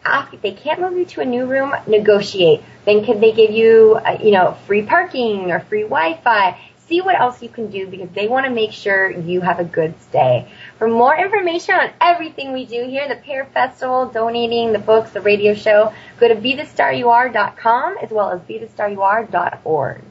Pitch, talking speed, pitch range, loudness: 225 Hz, 190 wpm, 210-260 Hz, -16 LUFS